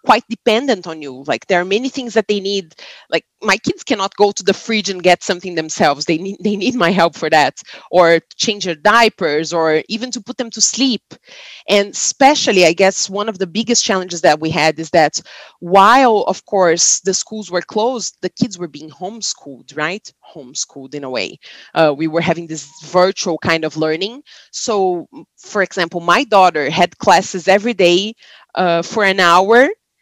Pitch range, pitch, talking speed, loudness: 165-220 Hz, 190 Hz, 190 wpm, -15 LUFS